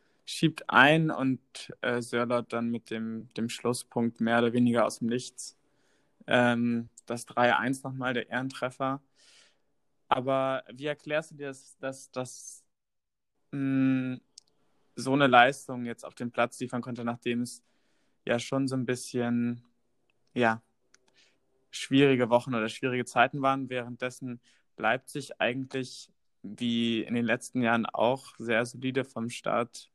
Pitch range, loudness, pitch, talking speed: 120-135 Hz, -29 LUFS, 125 Hz, 130 wpm